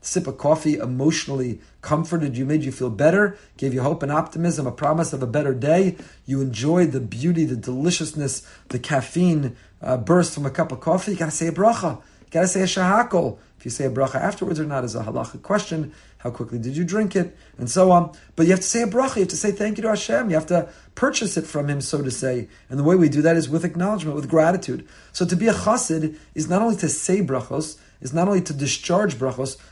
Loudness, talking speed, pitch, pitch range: -22 LUFS, 240 wpm, 155 Hz, 135-180 Hz